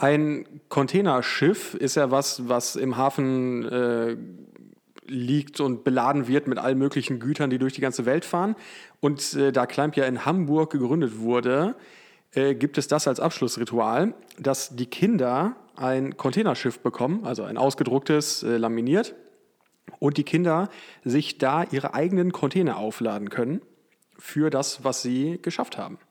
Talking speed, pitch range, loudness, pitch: 150 wpm, 130-155 Hz, -25 LUFS, 140 Hz